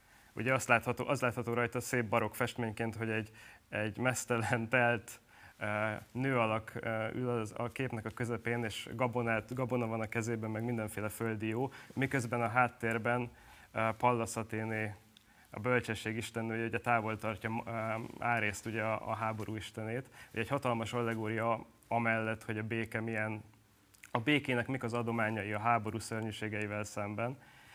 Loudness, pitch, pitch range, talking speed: -35 LUFS, 115 Hz, 110-120 Hz, 145 wpm